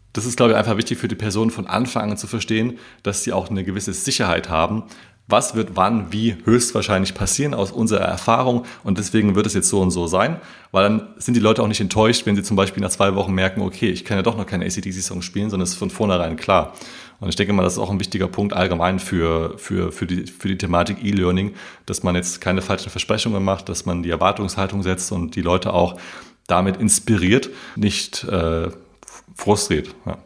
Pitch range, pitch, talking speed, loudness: 95-110 Hz, 100 Hz, 220 wpm, -20 LUFS